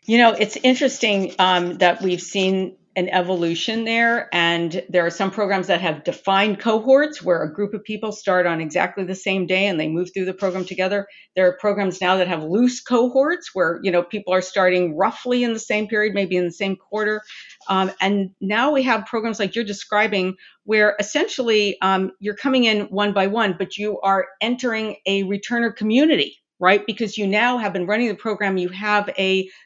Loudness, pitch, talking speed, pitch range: -20 LUFS, 200 Hz, 200 wpm, 185-220 Hz